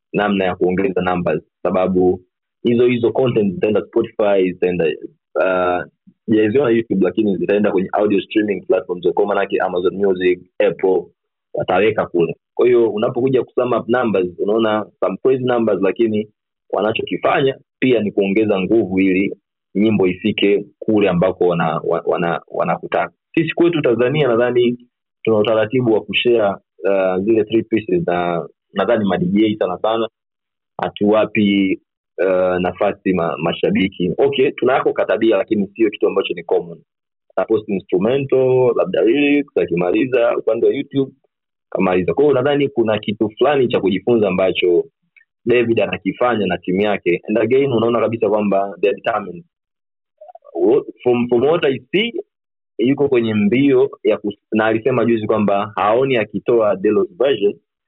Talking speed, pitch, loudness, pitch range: 120 wpm, 115 Hz, -17 LUFS, 100-165 Hz